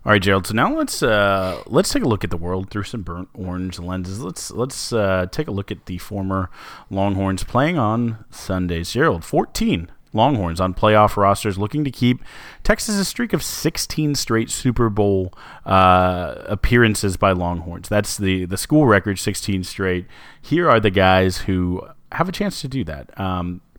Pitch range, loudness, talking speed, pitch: 95-115 Hz, -20 LUFS, 180 wpm, 100 Hz